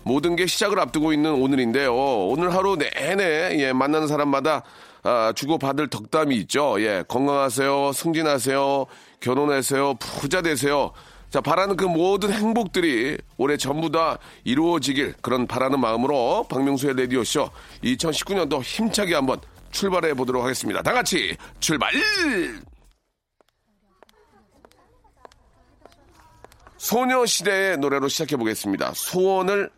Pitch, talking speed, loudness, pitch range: 150 Hz, 285 characters per minute, -22 LUFS, 135-190 Hz